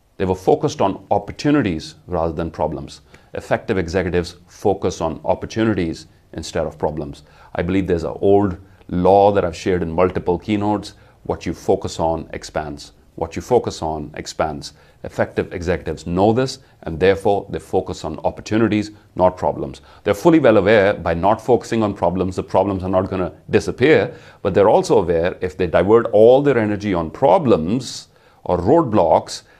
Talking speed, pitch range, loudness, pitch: 160 wpm, 85-105 Hz, -18 LUFS, 95 Hz